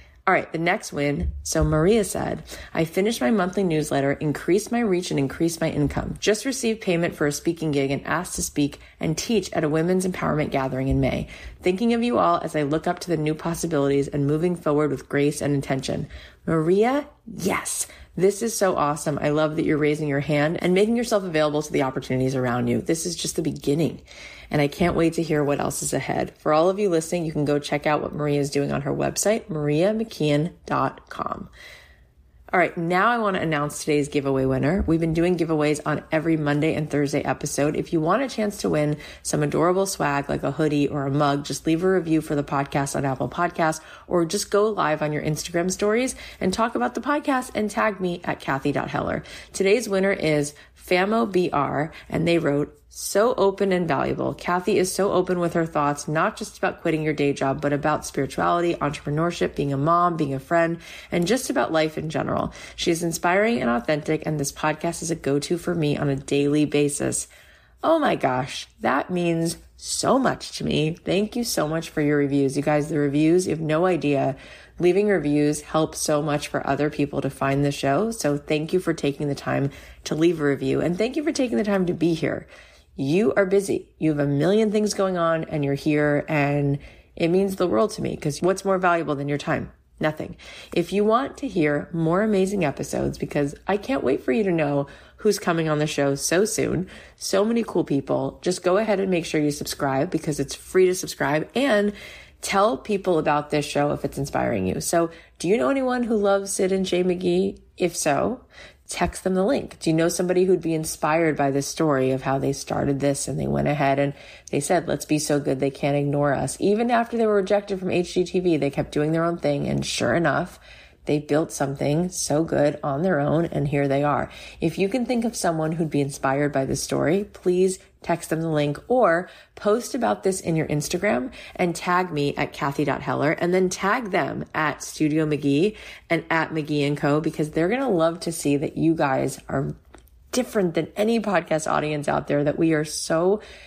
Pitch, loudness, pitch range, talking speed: 160 Hz, -23 LUFS, 145-185 Hz, 215 wpm